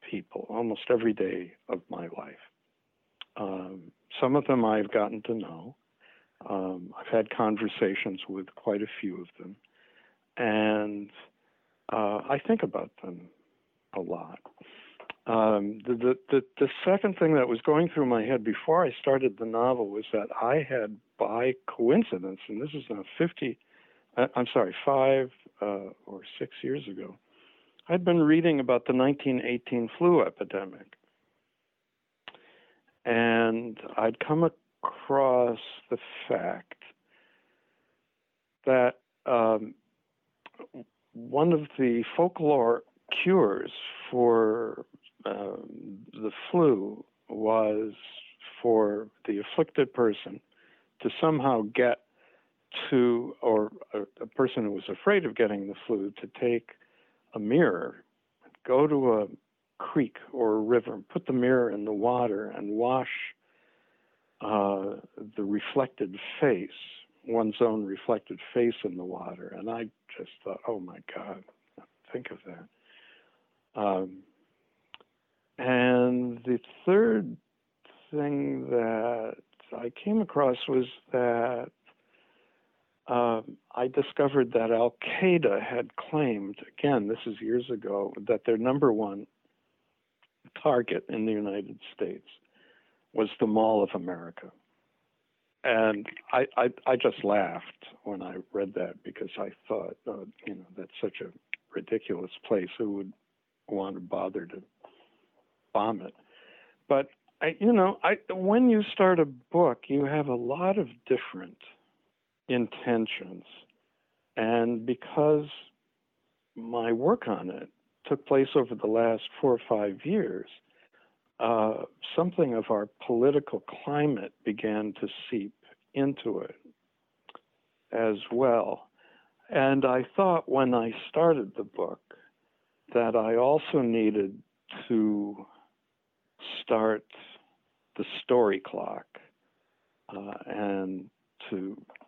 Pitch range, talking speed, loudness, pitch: 110-140 Hz, 120 wpm, -28 LUFS, 120 Hz